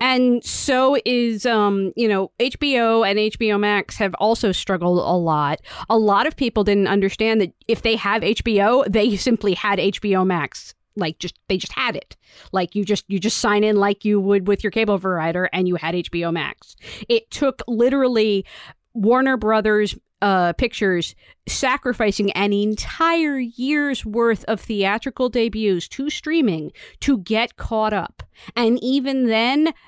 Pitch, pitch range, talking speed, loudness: 215 Hz, 195-245 Hz, 160 wpm, -20 LUFS